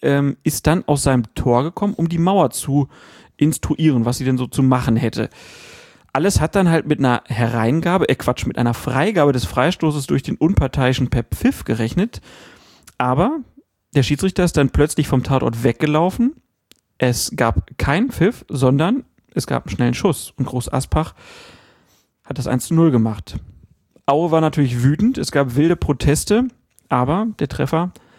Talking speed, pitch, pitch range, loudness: 165 wpm, 140 Hz, 125-165 Hz, -18 LUFS